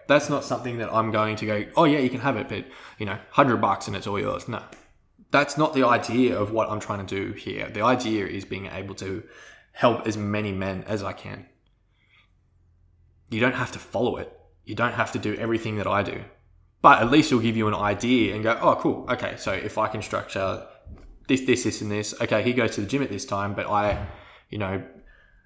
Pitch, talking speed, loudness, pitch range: 110 Hz, 235 wpm, -24 LUFS, 100-125 Hz